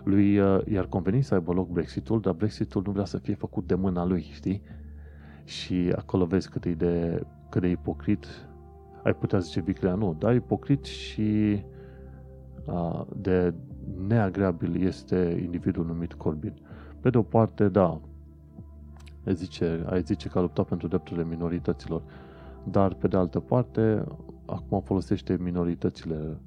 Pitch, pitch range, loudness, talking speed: 90 Hz, 75-100 Hz, -28 LUFS, 145 wpm